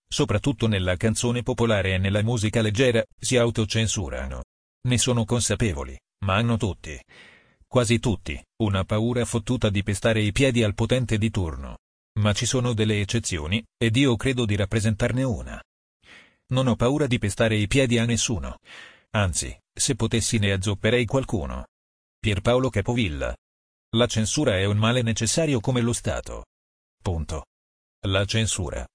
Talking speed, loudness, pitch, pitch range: 145 wpm, -24 LUFS, 110 Hz, 95-120 Hz